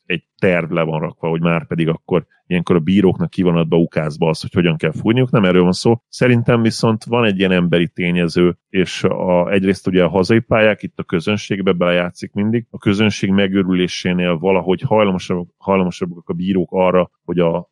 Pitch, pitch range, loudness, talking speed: 95 Hz, 90-105 Hz, -16 LUFS, 180 wpm